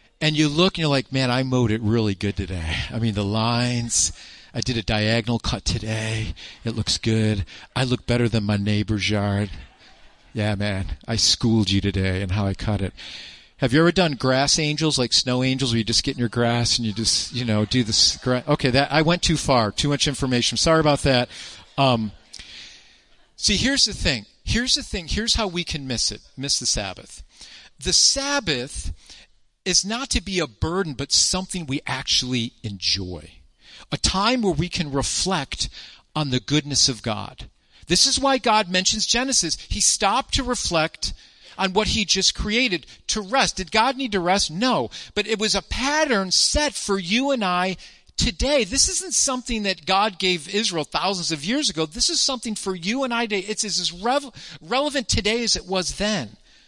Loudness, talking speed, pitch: -21 LUFS, 195 wpm, 145 Hz